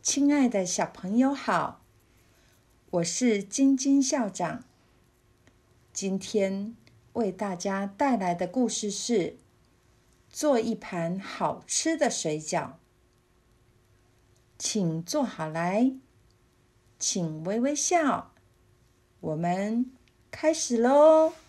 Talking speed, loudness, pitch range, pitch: 125 characters per minute, -27 LUFS, 150-250 Hz, 195 Hz